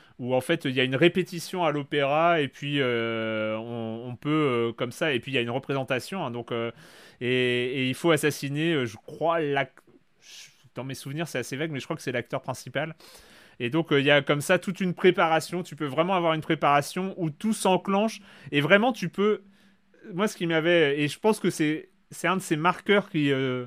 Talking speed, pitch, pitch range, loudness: 230 wpm, 150 Hz, 130-175 Hz, -26 LUFS